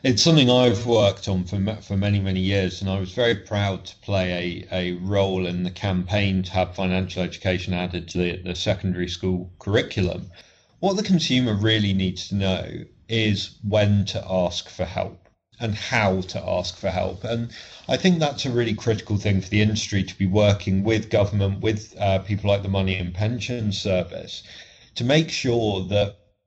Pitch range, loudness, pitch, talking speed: 95-110 Hz, -23 LUFS, 100 Hz, 185 wpm